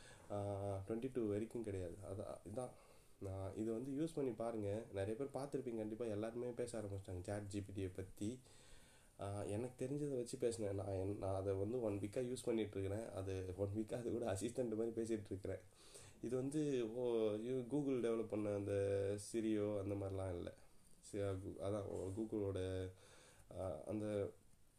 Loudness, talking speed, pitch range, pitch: -45 LUFS, 140 wpm, 100-120 Hz, 105 Hz